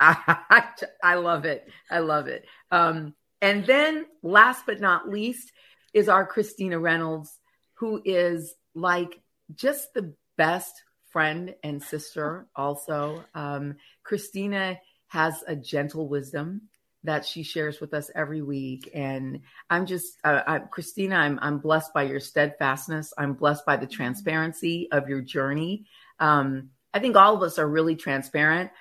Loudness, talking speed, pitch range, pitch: -24 LUFS, 145 wpm, 145-185 Hz, 160 Hz